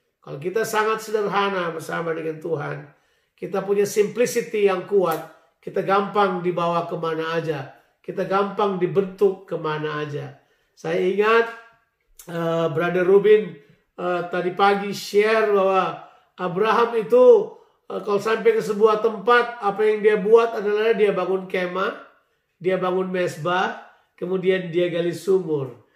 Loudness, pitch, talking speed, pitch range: -21 LUFS, 195 Hz, 125 wpm, 175-215 Hz